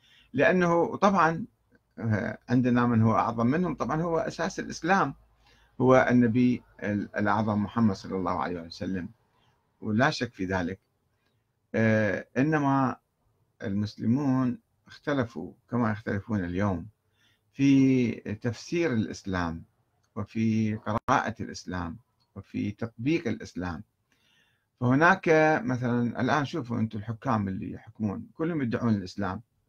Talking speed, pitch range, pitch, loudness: 100 wpm, 105-125 Hz, 115 Hz, -27 LUFS